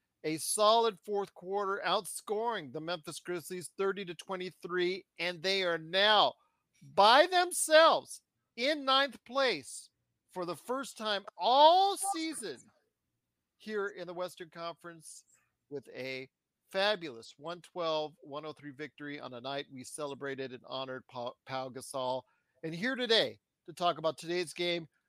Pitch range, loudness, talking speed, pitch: 150-210 Hz, -31 LUFS, 125 wpm, 175 Hz